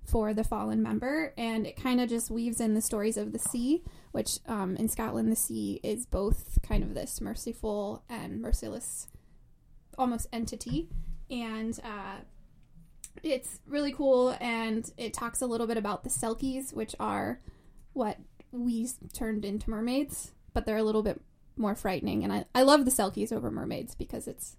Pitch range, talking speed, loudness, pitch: 210-245 Hz, 170 wpm, -32 LUFS, 225 Hz